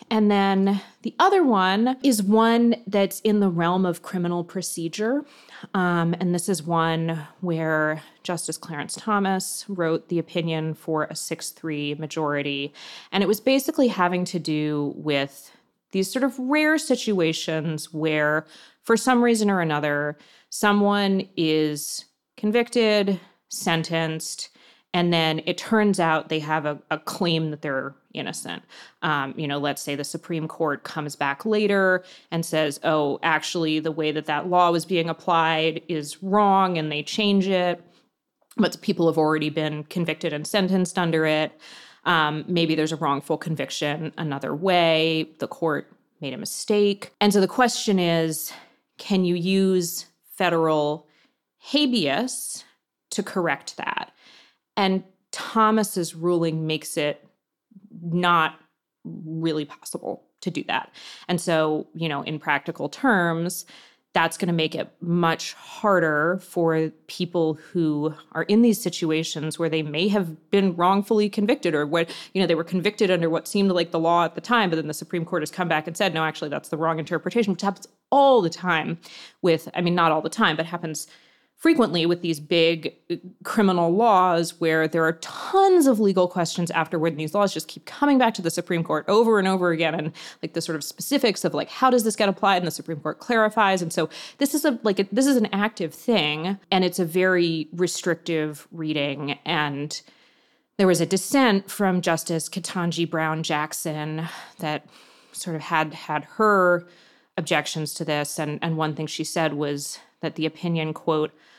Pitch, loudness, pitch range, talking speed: 170 Hz, -23 LUFS, 155-195 Hz, 170 wpm